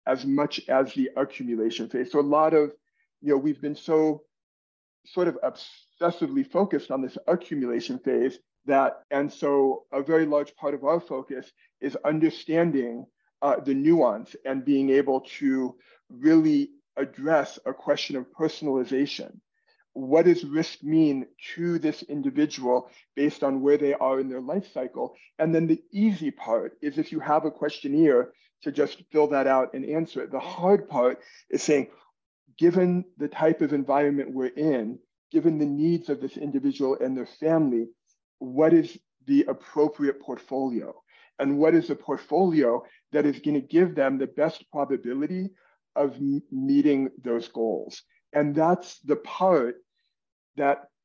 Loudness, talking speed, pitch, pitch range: -25 LUFS, 155 wpm, 145 Hz, 135-165 Hz